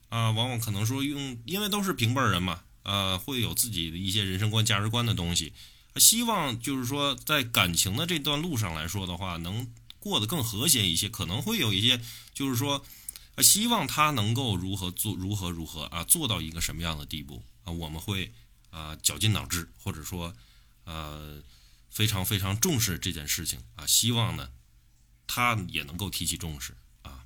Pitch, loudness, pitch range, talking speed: 100 Hz, -27 LUFS, 85-120 Hz, 275 characters per minute